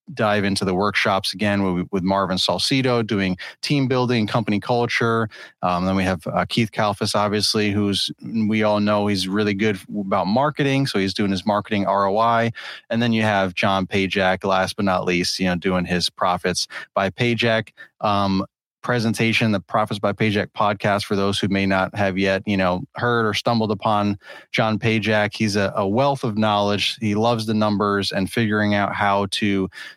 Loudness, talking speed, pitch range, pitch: -20 LUFS, 180 wpm, 95-110 Hz, 105 Hz